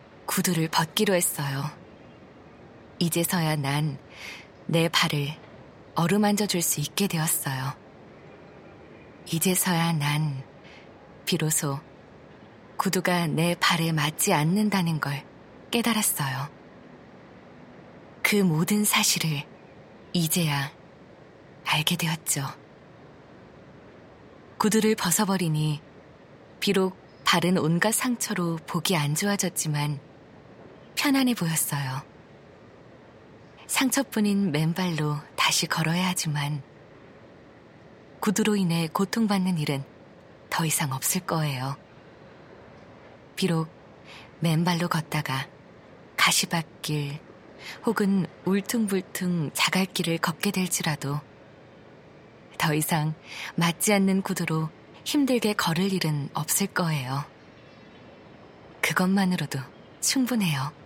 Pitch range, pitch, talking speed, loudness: 150-190 Hz, 170 Hz, 190 characters per minute, -25 LUFS